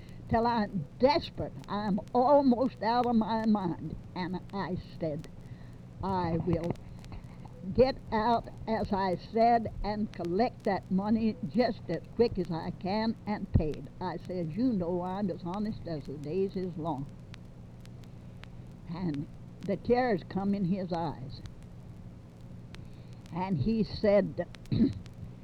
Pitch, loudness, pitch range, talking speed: 185 Hz, -31 LUFS, 155-215 Hz, 125 wpm